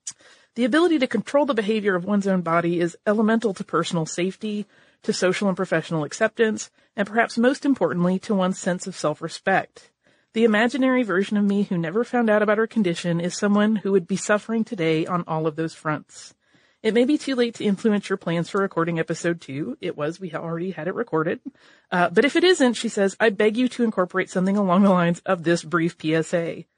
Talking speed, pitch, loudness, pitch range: 210 wpm, 195 Hz, -22 LUFS, 175-225 Hz